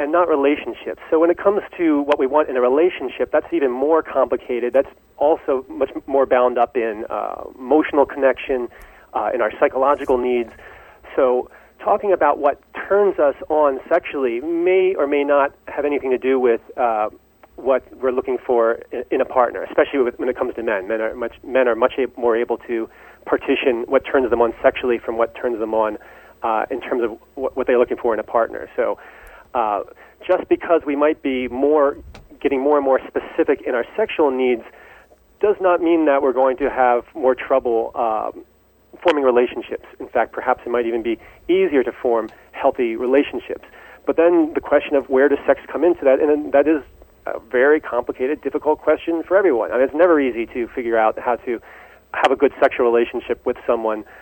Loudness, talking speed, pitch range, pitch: -19 LUFS, 200 wpm, 125-165 Hz, 140 Hz